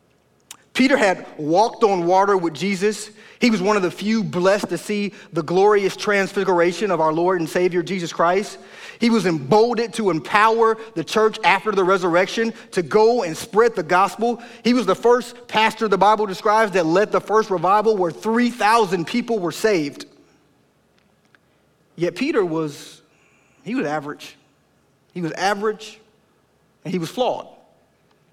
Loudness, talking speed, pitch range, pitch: -19 LUFS, 155 wpm, 180-220 Hz, 200 Hz